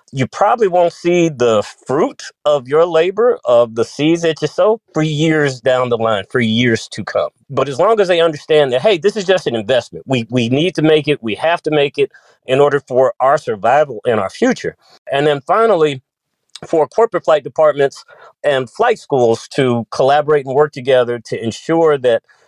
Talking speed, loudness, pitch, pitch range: 200 wpm, -15 LUFS, 150 Hz, 130-165 Hz